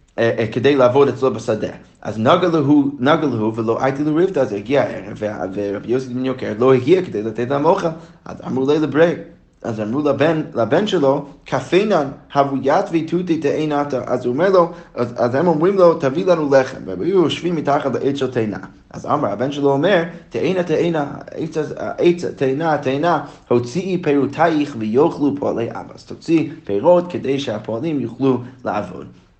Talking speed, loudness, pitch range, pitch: 160 wpm, -18 LUFS, 125-165 Hz, 140 Hz